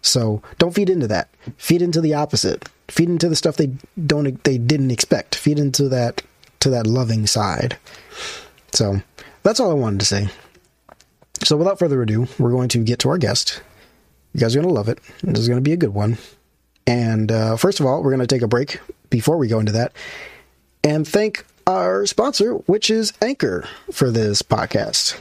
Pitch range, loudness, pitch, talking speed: 115-160 Hz, -19 LUFS, 130 Hz, 200 wpm